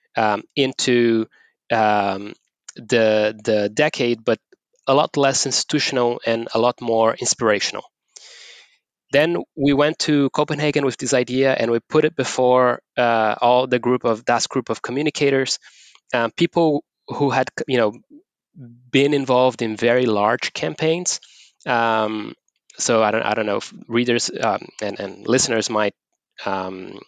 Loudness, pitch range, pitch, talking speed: -19 LUFS, 115-145 Hz, 125 Hz, 145 wpm